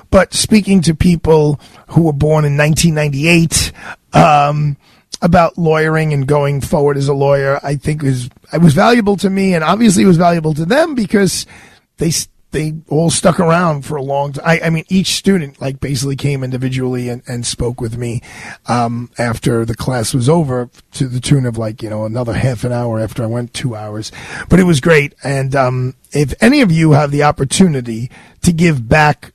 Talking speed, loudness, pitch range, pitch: 195 wpm, -13 LUFS, 125-165 Hz, 145 Hz